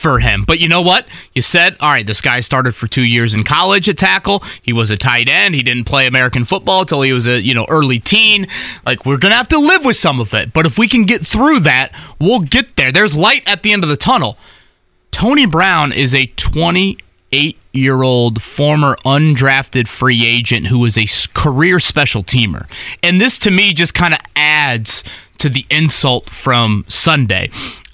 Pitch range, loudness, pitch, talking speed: 120-175 Hz, -11 LUFS, 140 Hz, 205 wpm